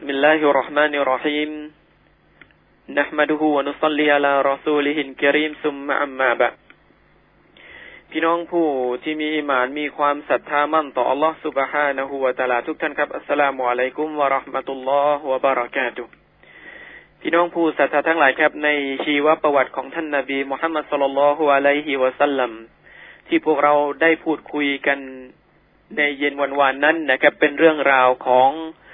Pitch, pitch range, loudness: 145 Hz, 135-150 Hz, -19 LUFS